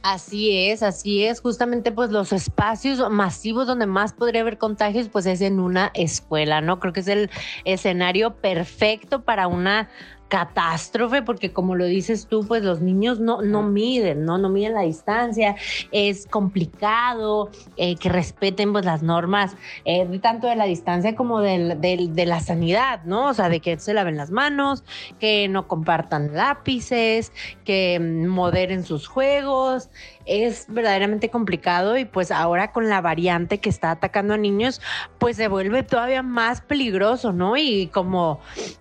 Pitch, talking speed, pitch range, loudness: 205 Hz, 160 wpm, 180-230 Hz, -21 LUFS